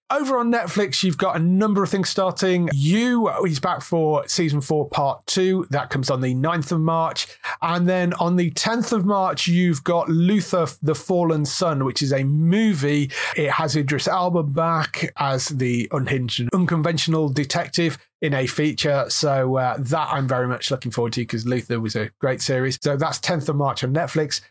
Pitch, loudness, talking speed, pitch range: 160 Hz, -21 LUFS, 190 wpm, 140-180 Hz